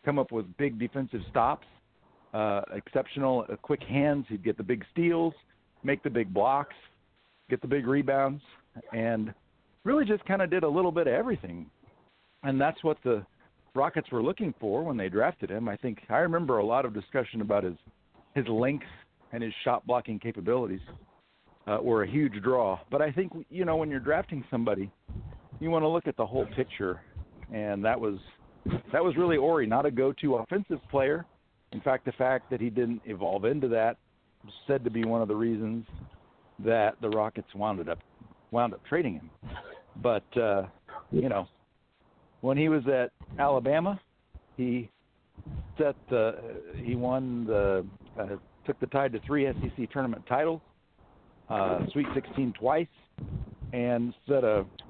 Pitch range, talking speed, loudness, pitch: 110-140 Hz, 170 wpm, -30 LUFS, 125 Hz